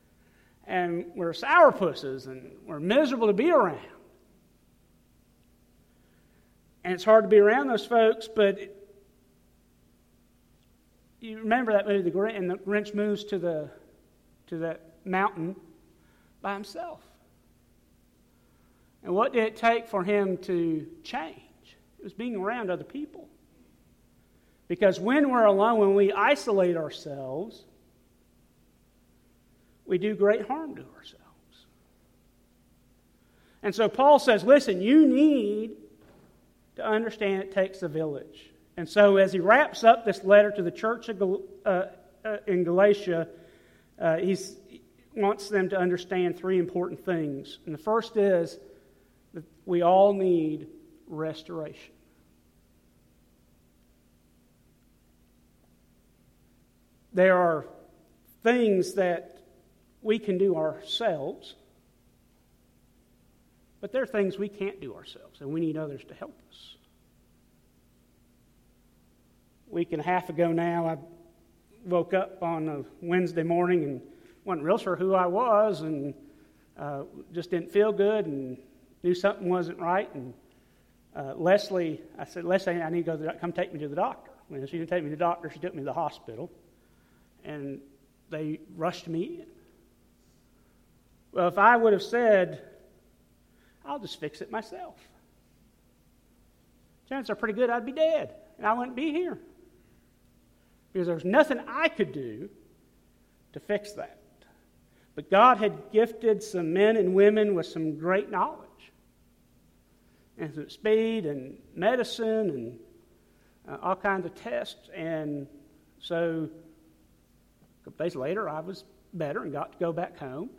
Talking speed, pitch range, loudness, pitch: 135 wpm, 165-215 Hz, -26 LUFS, 190 Hz